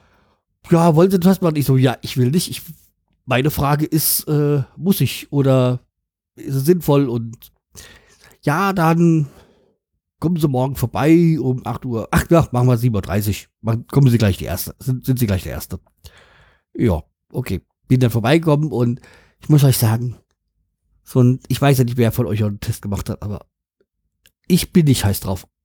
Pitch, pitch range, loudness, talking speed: 125 Hz, 105-150 Hz, -18 LUFS, 185 wpm